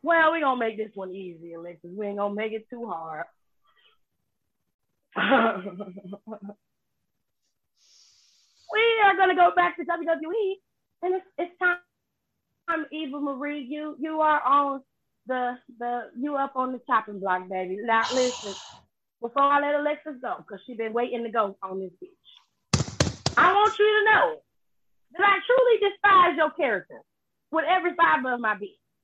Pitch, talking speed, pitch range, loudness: 280 Hz, 155 wpm, 220-350 Hz, -24 LUFS